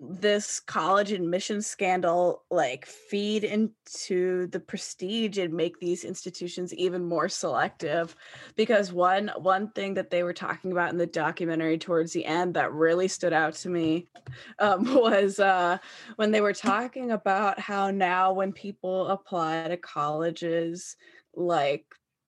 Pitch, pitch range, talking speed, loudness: 185 Hz, 170-200 Hz, 145 wpm, -27 LUFS